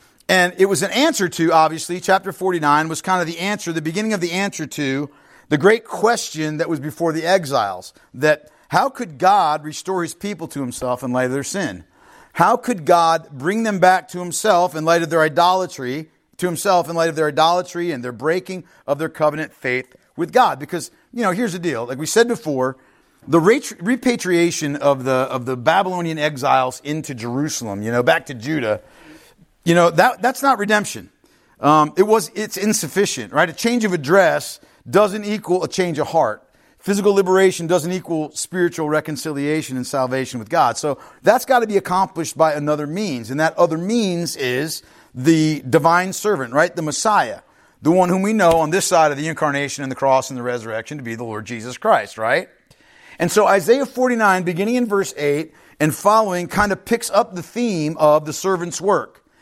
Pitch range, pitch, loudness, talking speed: 150-195 Hz, 170 Hz, -18 LUFS, 195 wpm